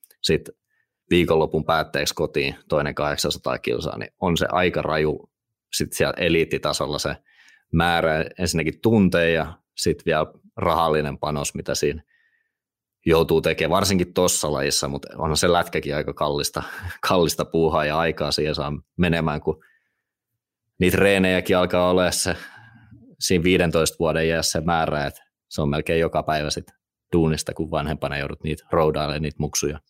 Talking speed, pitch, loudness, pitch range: 140 wpm, 80 Hz, -22 LUFS, 75-90 Hz